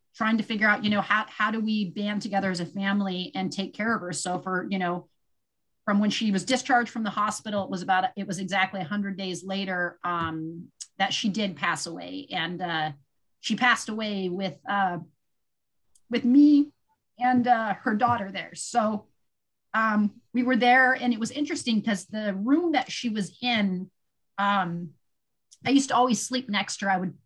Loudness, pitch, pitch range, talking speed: -26 LUFS, 205 Hz, 185-235 Hz, 195 wpm